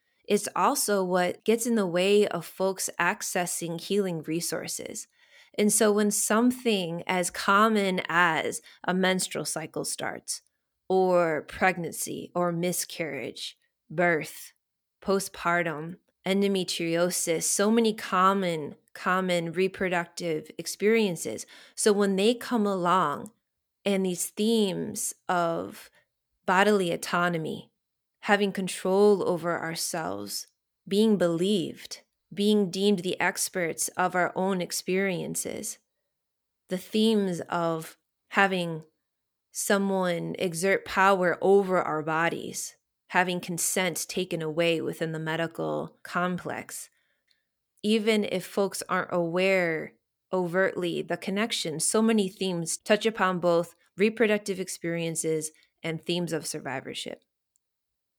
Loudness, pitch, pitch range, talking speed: -27 LUFS, 185 Hz, 170-205 Hz, 100 wpm